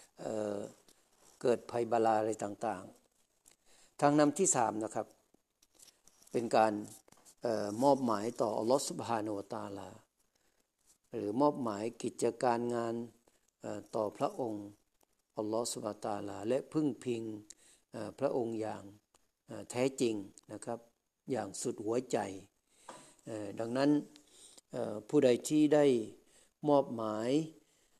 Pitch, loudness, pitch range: 115 Hz, -34 LUFS, 105-125 Hz